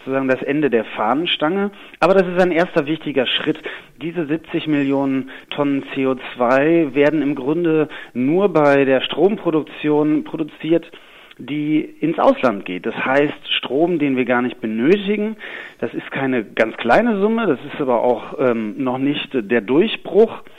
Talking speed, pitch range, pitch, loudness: 155 wpm, 135-175 Hz, 150 Hz, -18 LUFS